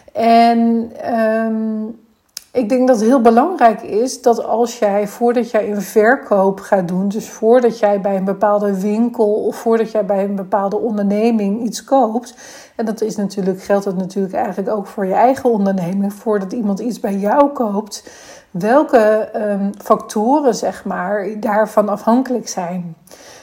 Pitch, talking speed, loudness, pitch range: 220 Hz, 155 wpm, -16 LUFS, 205-235 Hz